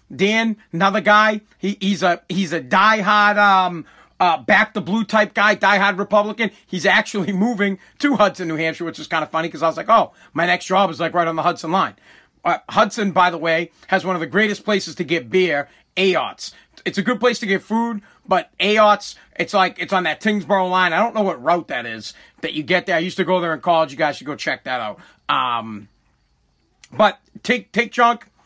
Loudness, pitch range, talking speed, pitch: -18 LUFS, 170-210 Hz, 225 wpm, 190 Hz